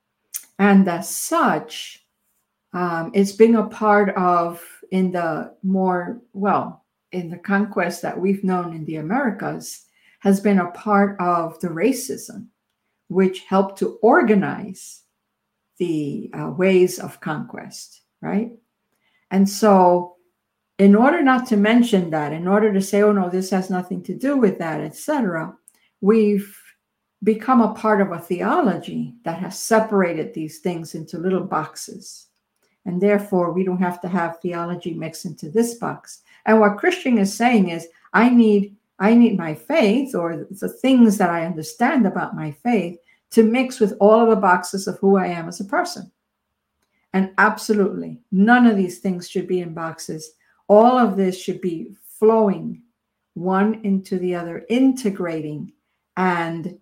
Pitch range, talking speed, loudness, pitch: 180-215 Hz, 155 wpm, -19 LUFS, 195 Hz